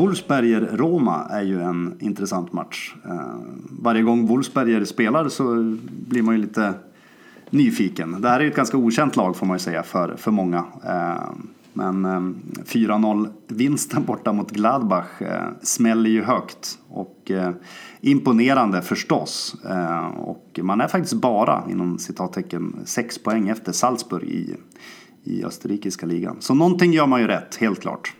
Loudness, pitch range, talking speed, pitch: -21 LUFS, 95-130 Hz, 150 wpm, 110 Hz